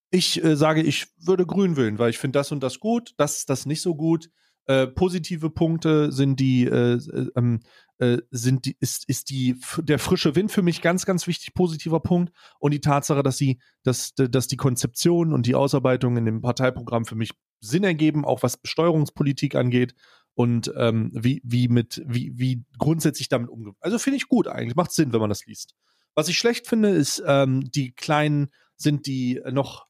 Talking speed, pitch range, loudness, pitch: 200 wpm, 125-165 Hz, -23 LUFS, 140 Hz